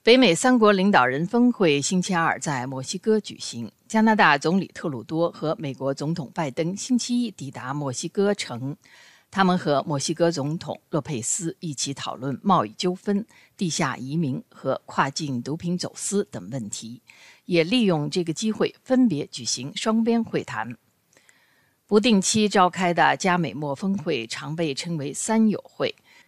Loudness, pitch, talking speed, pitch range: -23 LUFS, 170 Hz, 245 characters per minute, 140-205 Hz